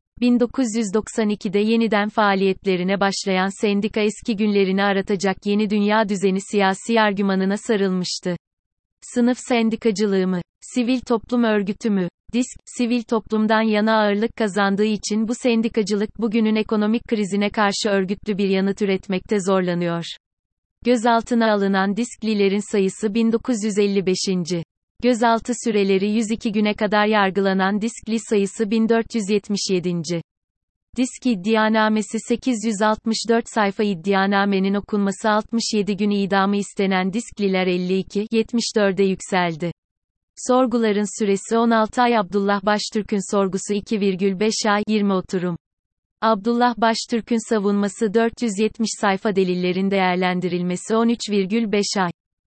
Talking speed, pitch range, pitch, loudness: 100 wpm, 195-225 Hz, 210 Hz, -20 LUFS